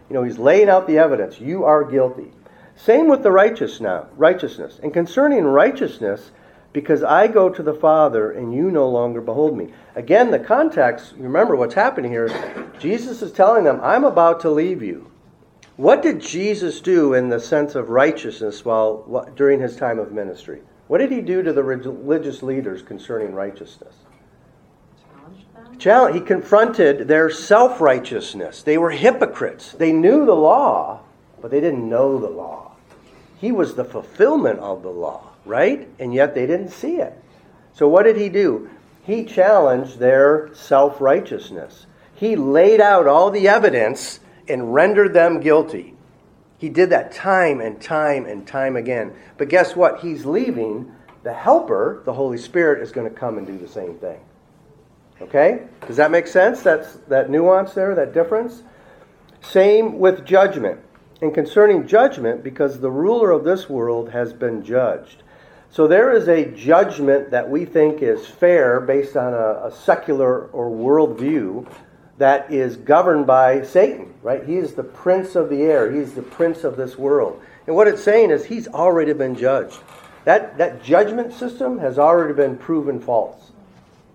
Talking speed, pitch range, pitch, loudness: 165 wpm, 135-195 Hz, 155 Hz, -17 LUFS